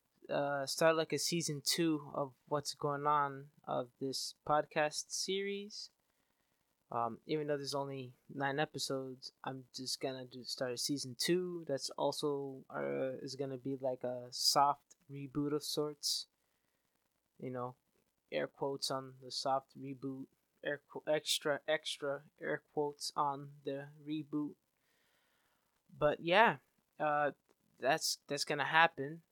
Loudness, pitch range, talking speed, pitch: -37 LUFS, 135-150 Hz, 135 wpm, 140 Hz